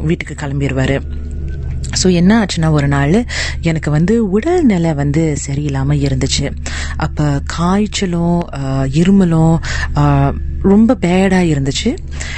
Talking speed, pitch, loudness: 90 wpm, 145 Hz, -14 LUFS